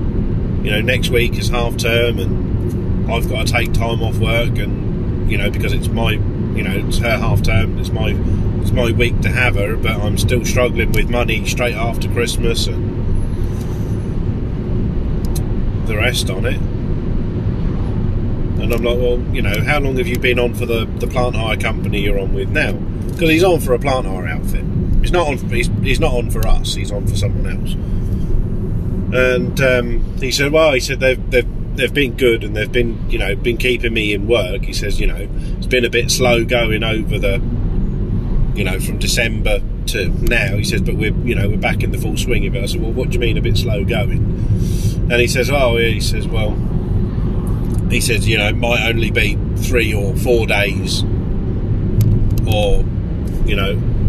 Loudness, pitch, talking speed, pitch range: -17 LUFS, 110 Hz, 200 wpm, 100-120 Hz